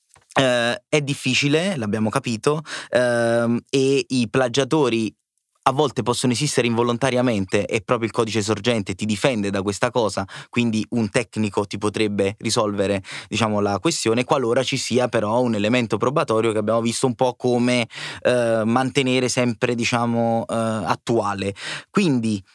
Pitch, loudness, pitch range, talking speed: 120 Hz, -21 LUFS, 110-125 Hz, 140 wpm